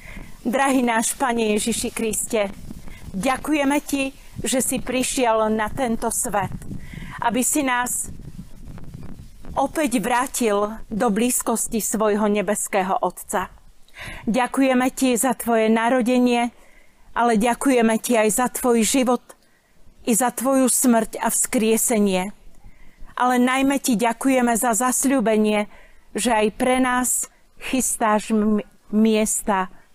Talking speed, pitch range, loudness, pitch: 110 wpm, 220-255 Hz, -20 LUFS, 235 Hz